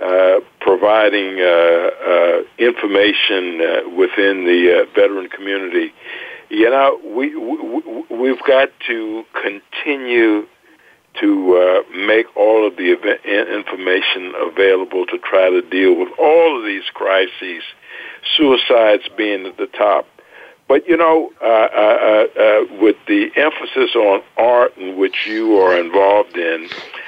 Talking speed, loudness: 130 wpm, -15 LUFS